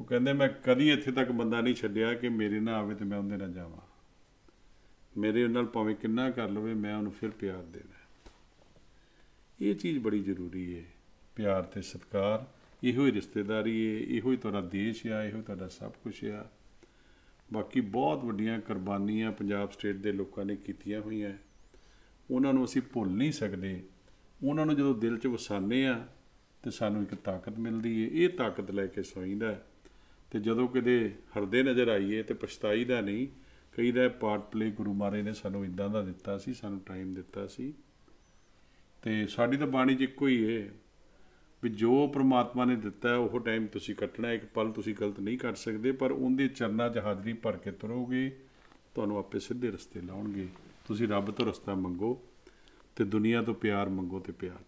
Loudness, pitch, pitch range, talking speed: -32 LUFS, 110 Hz, 100-120 Hz, 175 wpm